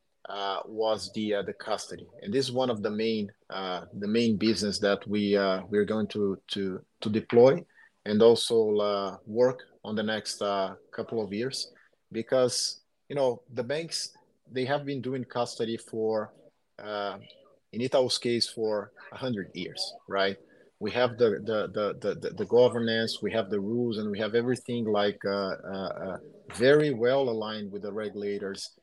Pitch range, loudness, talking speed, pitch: 100-120 Hz, -29 LUFS, 175 wpm, 110 Hz